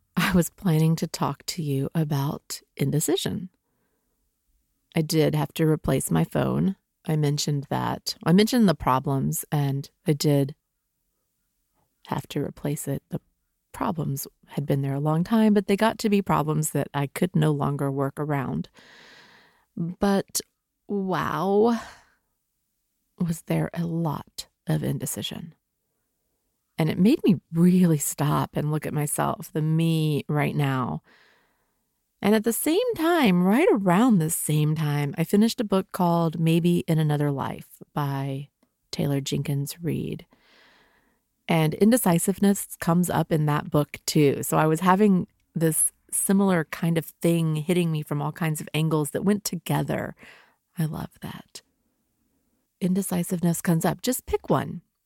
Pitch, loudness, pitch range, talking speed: 165 Hz, -24 LUFS, 145-190 Hz, 145 wpm